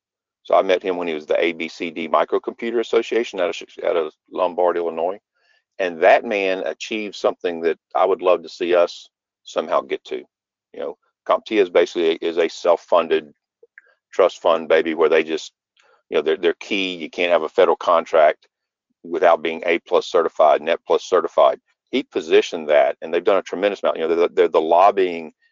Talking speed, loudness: 185 wpm, -19 LUFS